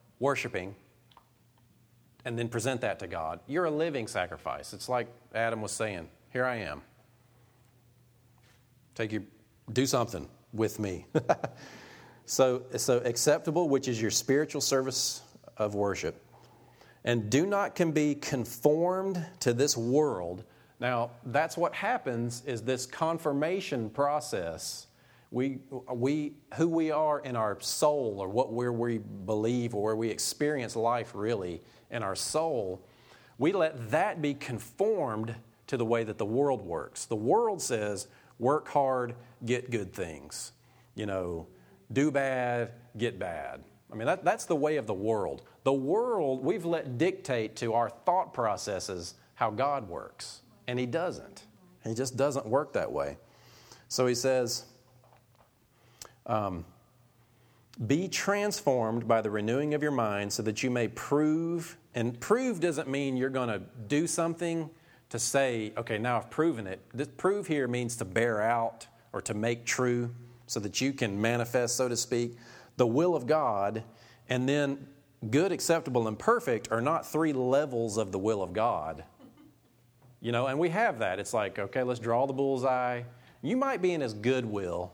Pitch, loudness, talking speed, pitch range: 125 Hz, -31 LUFS, 155 wpm, 115-140 Hz